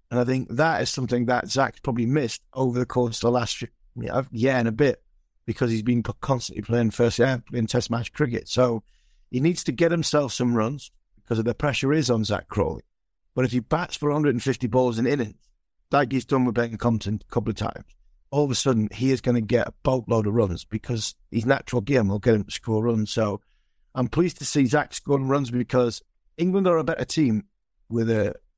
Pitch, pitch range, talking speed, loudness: 125 Hz, 115-135 Hz, 225 wpm, -24 LUFS